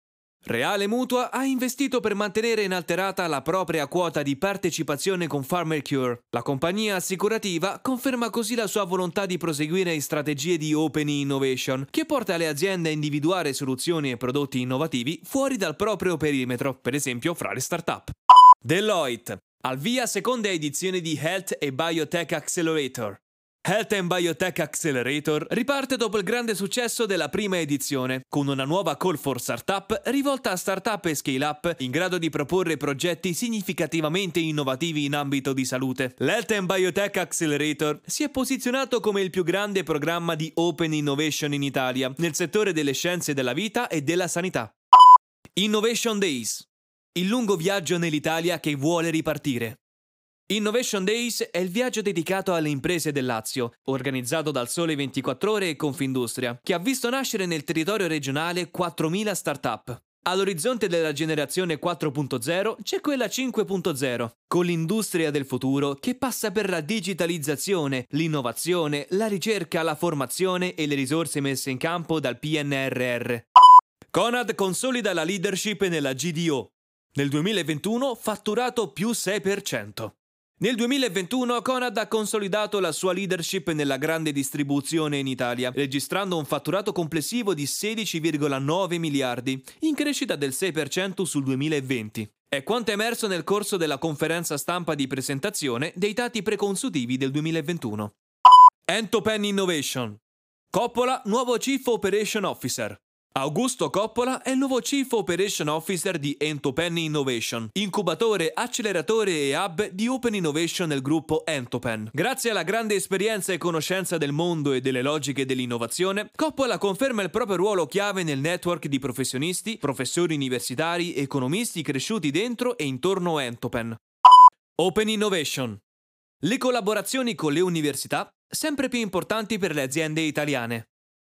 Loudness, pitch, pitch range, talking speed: -24 LUFS, 170 Hz, 145-210 Hz, 140 wpm